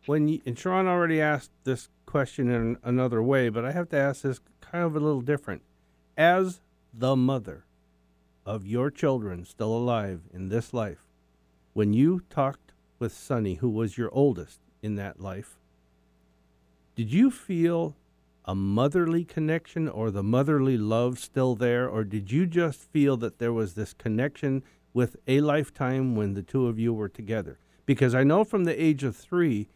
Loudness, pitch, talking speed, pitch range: -27 LUFS, 120 Hz, 170 wpm, 100-145 Hz